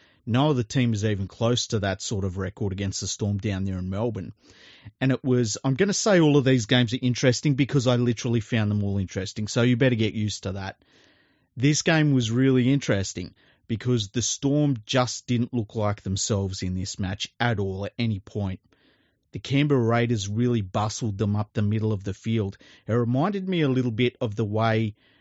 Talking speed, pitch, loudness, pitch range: 205 wpm, 115 Hz, -25 LUFS, 100-125 Hz